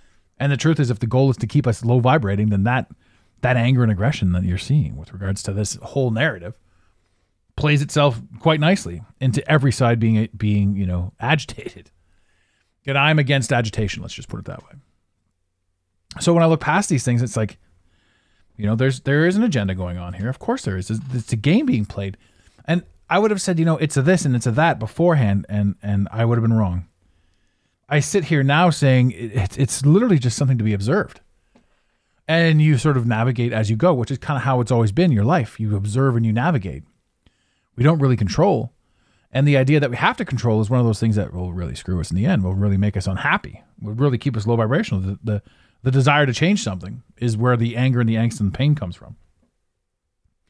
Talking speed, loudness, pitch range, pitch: 225 wpm, -19 LUFS, 100-140 Hz, 115 Hz